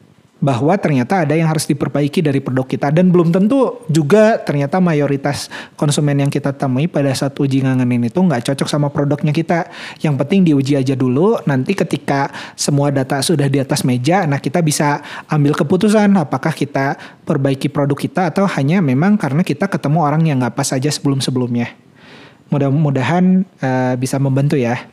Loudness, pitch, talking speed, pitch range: -15 LUFS, 145 Hz, 165 wpm, 140-170 Hz